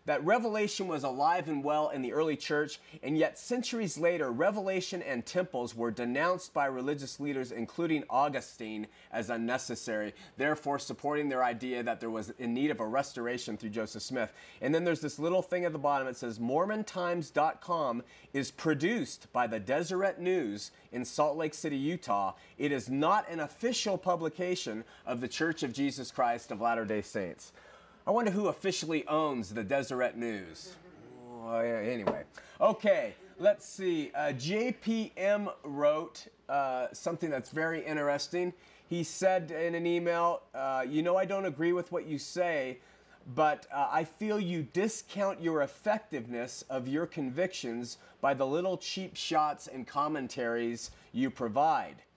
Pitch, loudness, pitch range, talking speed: 150 Hz, -33 LUFS, 125-180 Hz, 155 wpm